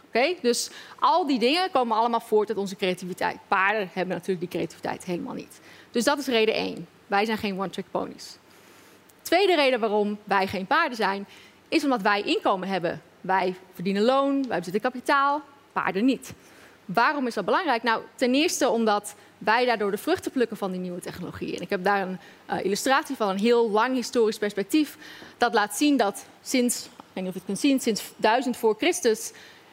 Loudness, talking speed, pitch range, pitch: -25 LUFS, 185 wpm, 195-255 Hz, 220 Hz